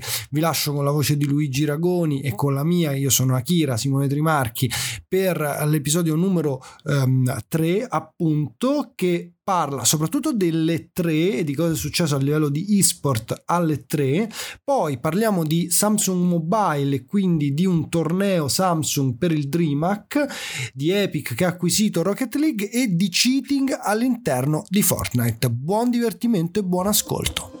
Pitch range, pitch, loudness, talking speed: 145-190 Hz, 165 Hz, -21 LUFS, 150 wpm